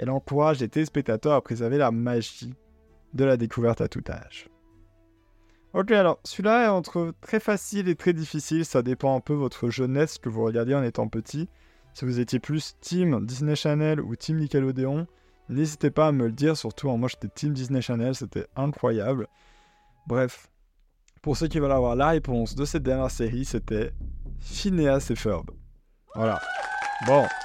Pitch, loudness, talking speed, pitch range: 130 Hz, -26 LUFS, 175 wpm, 115-155 Hz